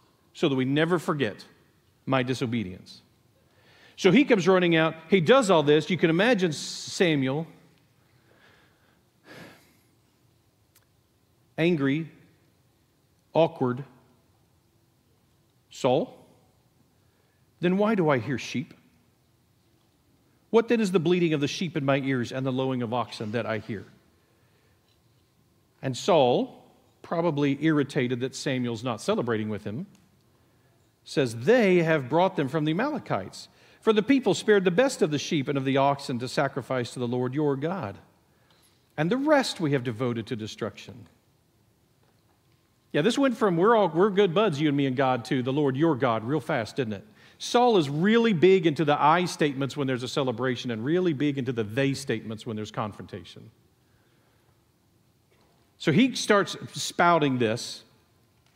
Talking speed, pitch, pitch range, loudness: 150 wpm, 135 Hz, 115-165 Hz, -25 LUFS